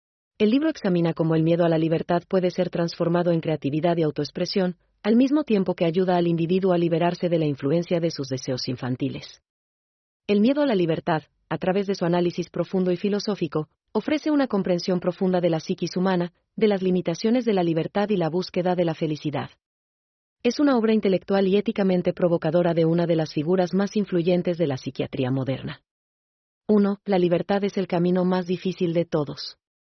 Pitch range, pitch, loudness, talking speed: 165-195 Hz, 175 Hz, -23 LUFS, 185 wpm